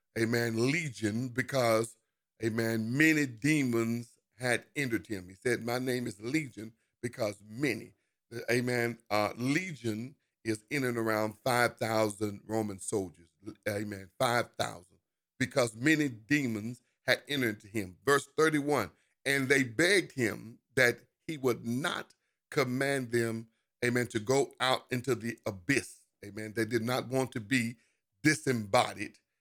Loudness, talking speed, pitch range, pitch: -31 LUFS, 135 wpm, 110-130 Hz, 120 Hz